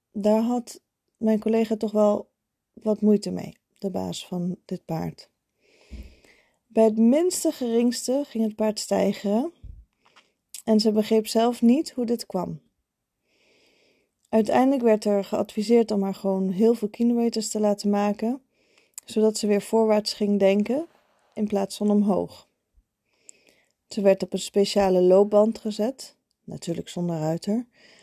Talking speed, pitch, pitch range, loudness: 135 wpm, 215 Hz, 200-230 Hz, -23 LUFS